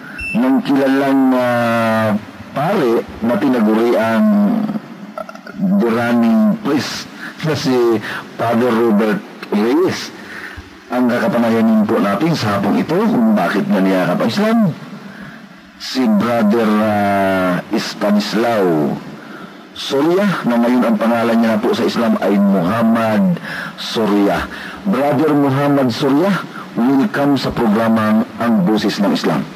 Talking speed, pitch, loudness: 110 wpm, 125 Hz, -15 LUFS